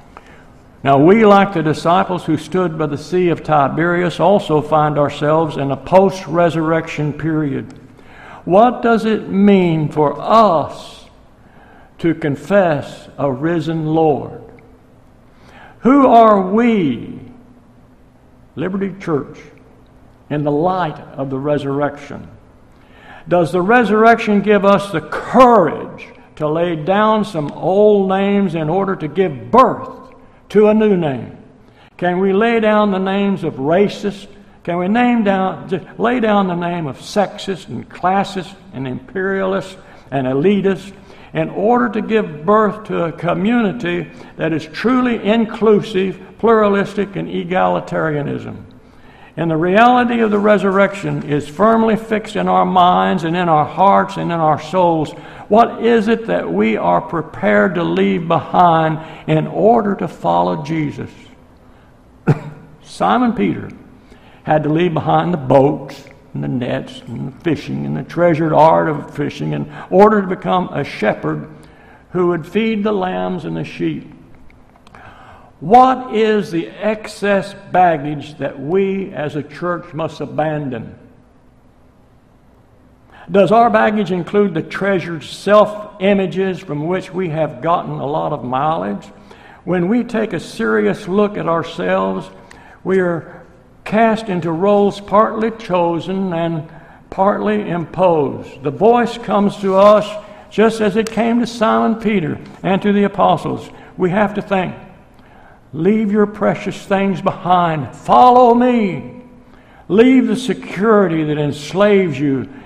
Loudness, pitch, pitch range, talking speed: -15 LUFS, 180 Hz, 155-205 Hz, 135 wpm